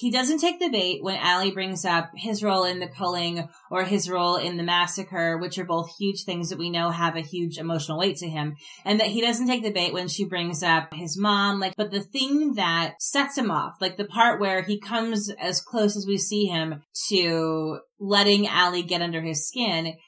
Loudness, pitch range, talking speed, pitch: -24 LUFS, 170-205 Hz, 225 wpm, 185 Hz